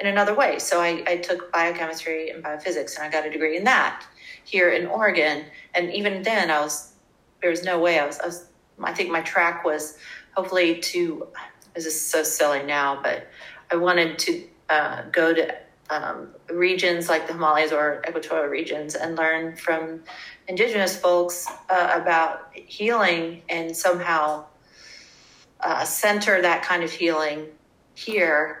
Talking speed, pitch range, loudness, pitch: 160 wpm, 155-180 Hz, -23 LUFS, 165 Hz